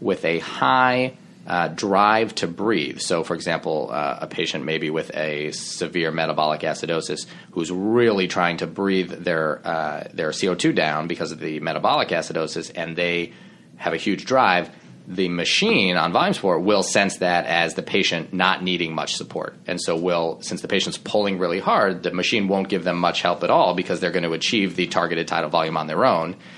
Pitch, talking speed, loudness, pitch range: 90 Hz, 190 wpm, -22 LUFS, 85-100 Hz